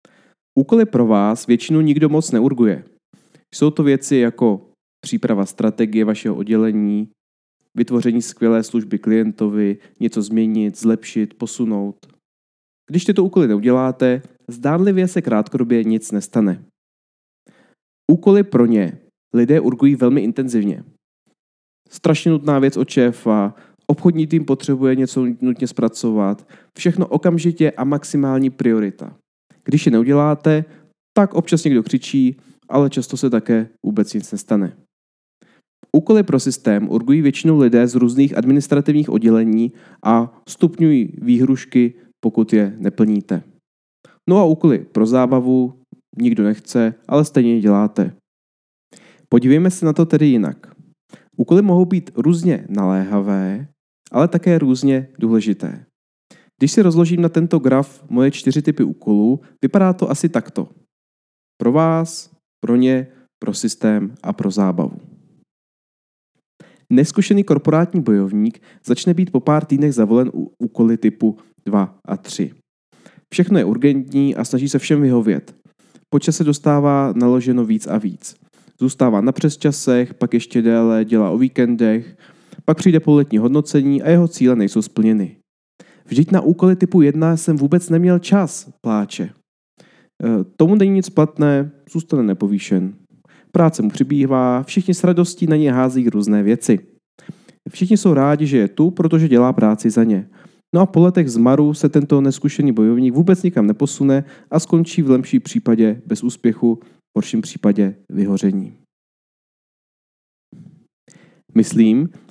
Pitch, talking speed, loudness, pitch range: 130 Hz, 130 wpm, -16 LUFS, 110-160 Hz